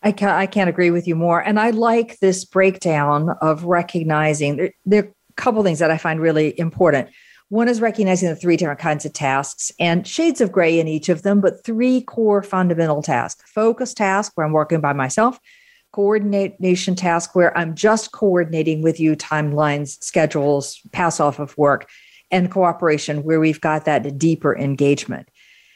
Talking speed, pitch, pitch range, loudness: 180 wpm, 170 Hz, 155-200 Hz, -18 LUFS